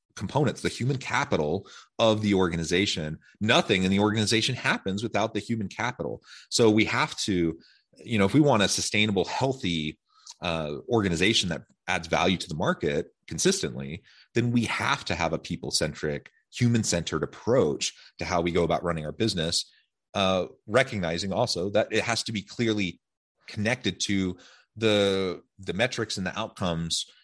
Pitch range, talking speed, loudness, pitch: 85-115 Hz, 155 wpm, -26 LUFS, 100 Hz